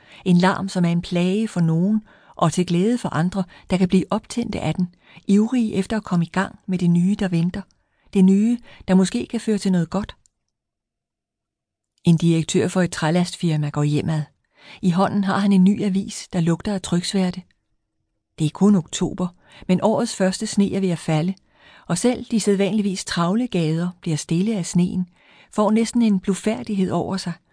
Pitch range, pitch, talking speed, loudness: 175-205 Hz, 185 Hz, 185 wpm, -21 LUFS